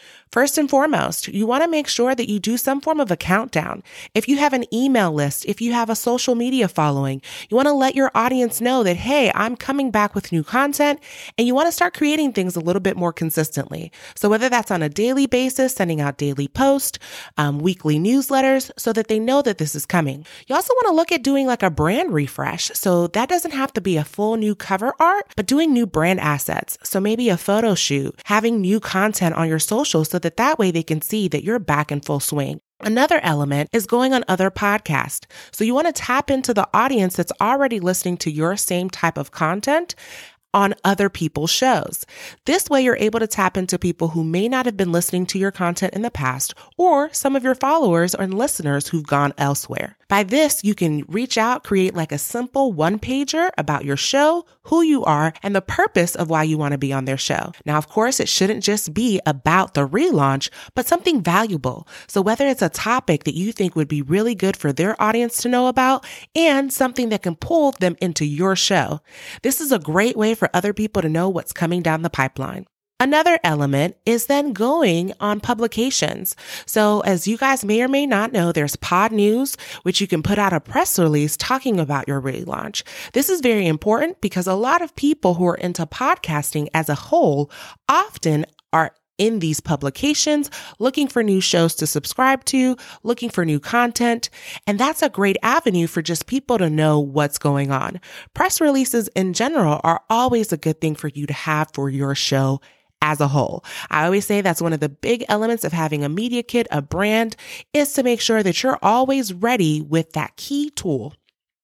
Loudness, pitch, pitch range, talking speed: -19 LUFS, 205 Hz, 165-255 Hz, 215 wpm